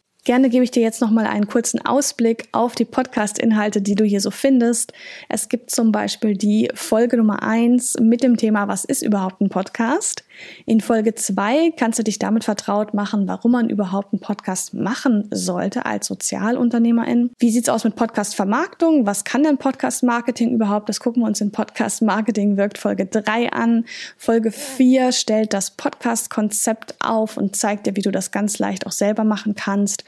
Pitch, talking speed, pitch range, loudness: 225 Hz, 180 wpm, 210-245 Hz, -19 LUFS